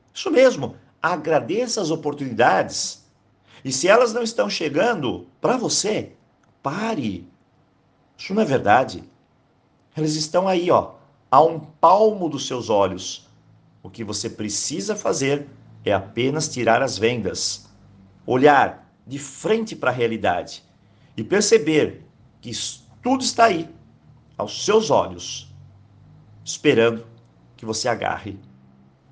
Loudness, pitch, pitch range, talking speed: -21 LUFS, 125 Hz, 105-160 Hz, 120 wpm